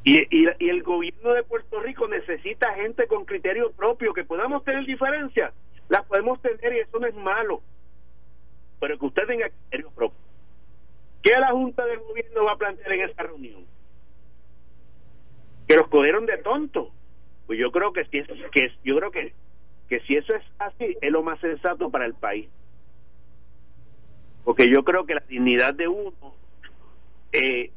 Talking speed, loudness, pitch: 170 wpm, -23 LUFS, 160 Hz